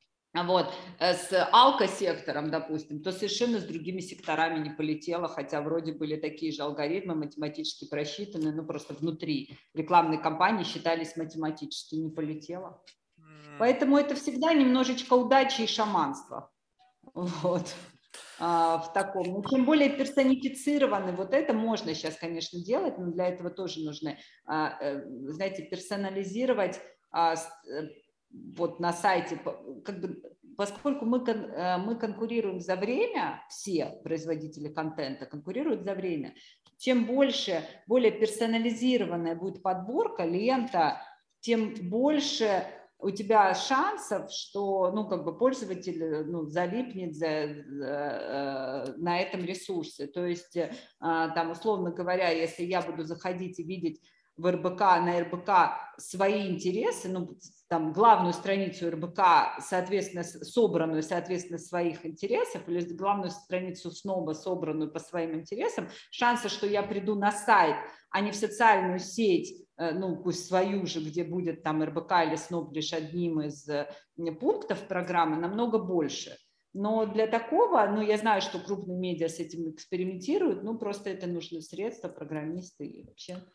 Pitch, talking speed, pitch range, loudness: 180 Hz, 130 wpm, 165-215 Hz, -30 LUFS